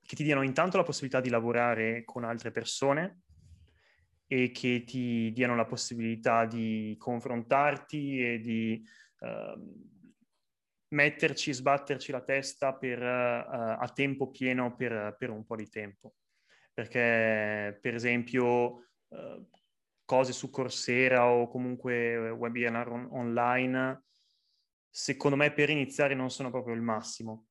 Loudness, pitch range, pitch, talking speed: -30 LUFS, 115-135 Hz, 125 Hz, 125 wpm